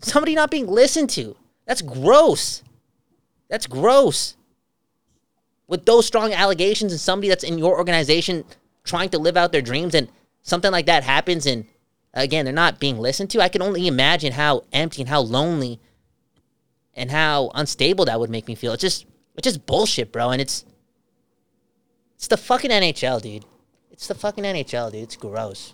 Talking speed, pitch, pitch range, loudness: 175 wpm, 165 Hz, 130-195 Hz, -20 LUFS